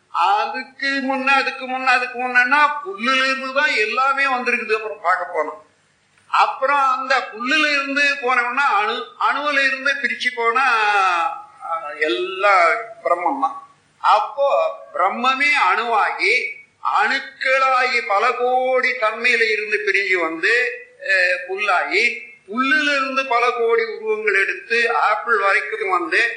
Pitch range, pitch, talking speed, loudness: 240-385 Hz, 265 Hz, 80 wpm, -18 LUFS